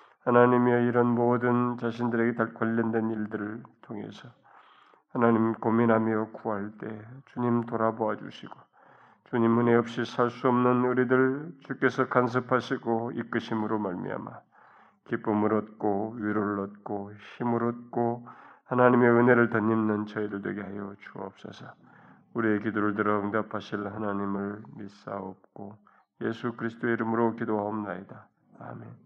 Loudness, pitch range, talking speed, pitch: -27 LUFS, 105-120 Hz, 305 characters per minute, 115 Hz